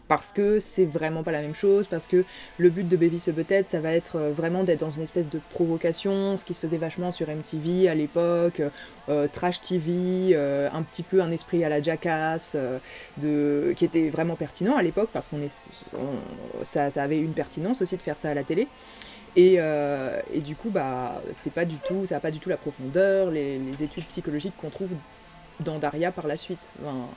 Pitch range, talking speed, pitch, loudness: 150-180 Hz, 215 wpm, 165 Hz, -26 LUFS